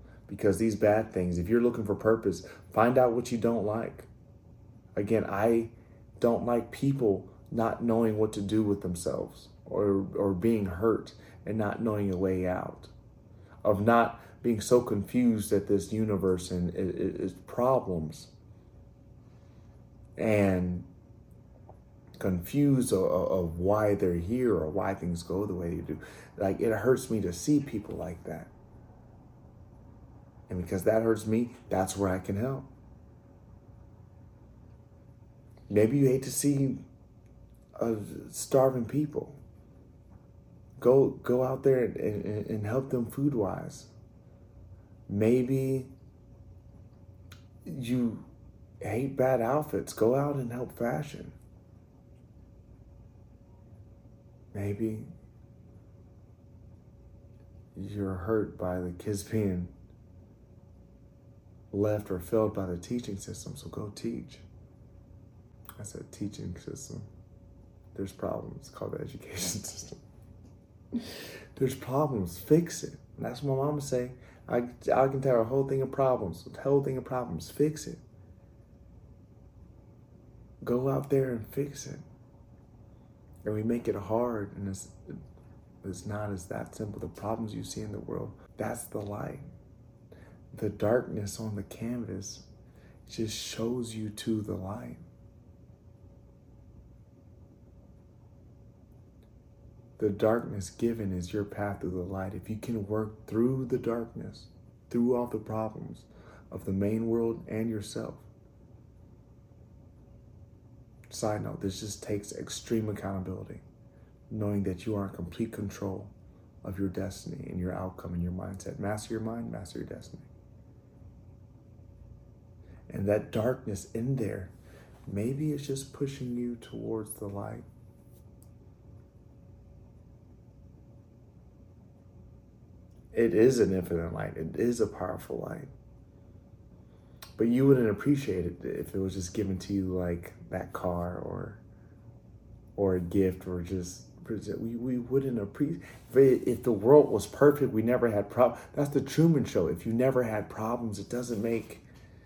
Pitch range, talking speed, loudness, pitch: 95-120 Hz, 130 wpm, -31 LUFS, 110 Hz